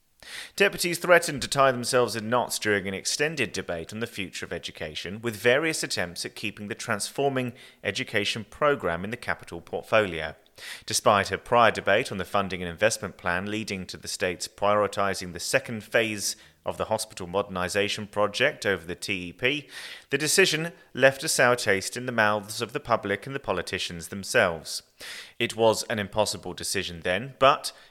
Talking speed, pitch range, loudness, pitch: 170 wpm, 100-125 Hz, -26 LUFS, 105 Hz